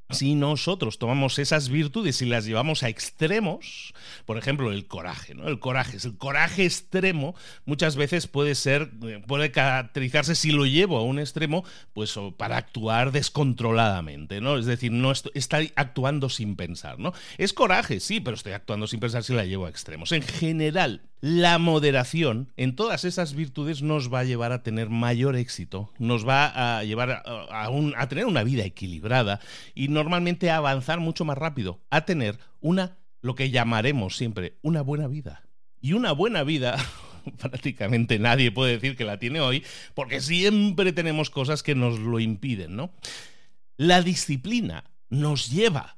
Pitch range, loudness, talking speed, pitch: 120-155 Hz, -25 LUFS, 165 wpm, 135 Hz